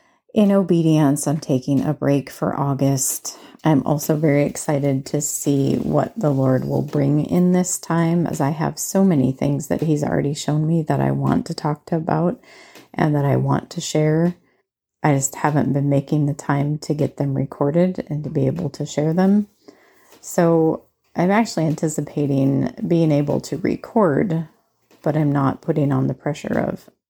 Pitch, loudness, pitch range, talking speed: 150 Hz, -20 LUFS, 140-165 Hz, 175 wpm